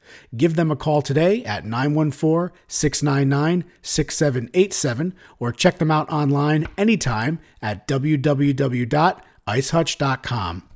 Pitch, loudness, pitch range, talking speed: 150 Hz, -21 LUFS, 135-160 Hz, 95 wpm